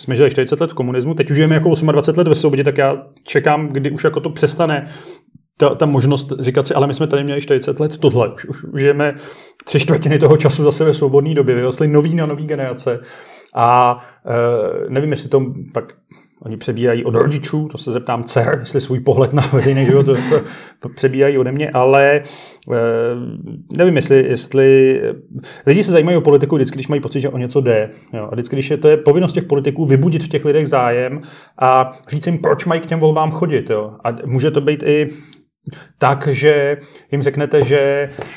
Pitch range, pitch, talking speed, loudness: 130-150 Hz, 145 Hz, 205 wpm, -15 LUFS